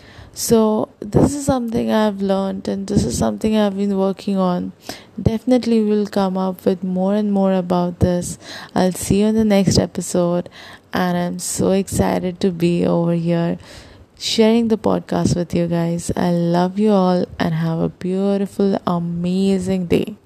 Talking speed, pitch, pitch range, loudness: 165 wpm, 190 Hz, 175-210 Hz, -18 LUFS